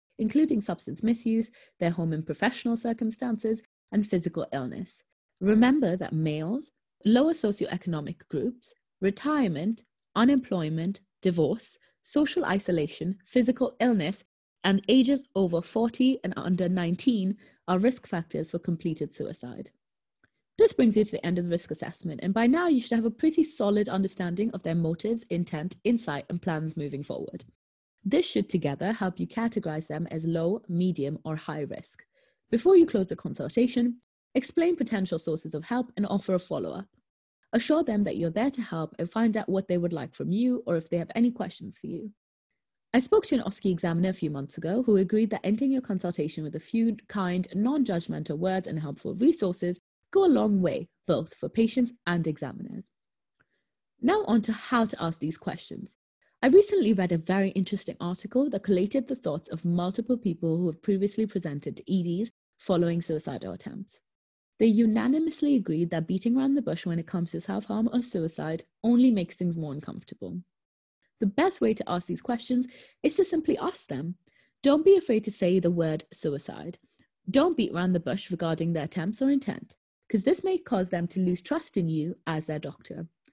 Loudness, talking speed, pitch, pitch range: -27 LUFS, 180 wpm, 195 Hz, 170-235 Hz